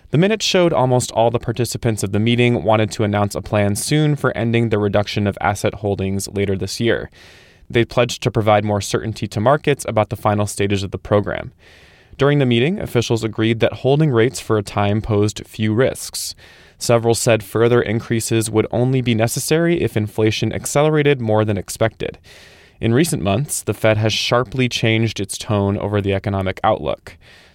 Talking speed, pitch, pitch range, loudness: 180 wpm, 110 Hz, 105-120 Hz, -18 LUFS